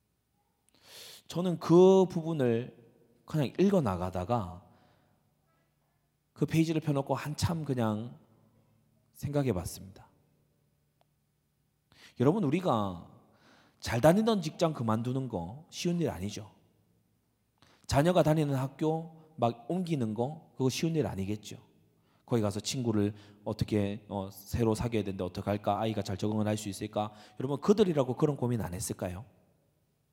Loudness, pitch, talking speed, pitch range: -31 LUFS, 120 Hz, 260 characters per minute, 105-150 Hz